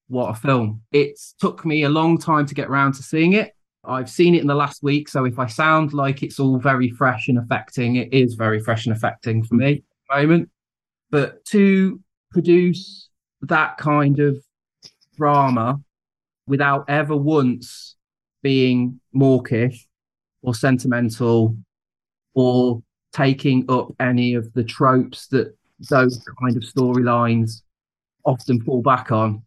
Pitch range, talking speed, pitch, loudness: 125-145 Hz, 150 wpm, 130 Hz, -19 LUFS